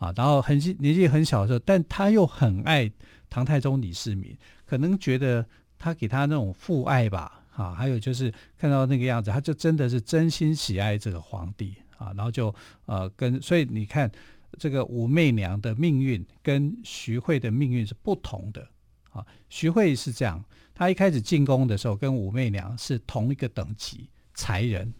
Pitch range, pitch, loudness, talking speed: 110-145 Hz, 125 Hz, -25 LUFS, 270 characters per minute